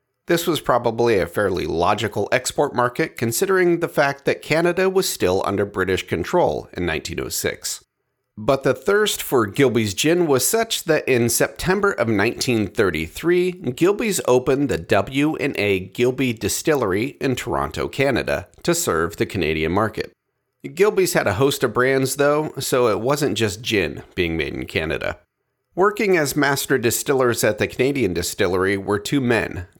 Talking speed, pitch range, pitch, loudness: 150 wpm, 105-170 Hz, 135 Hz, -20 LUFS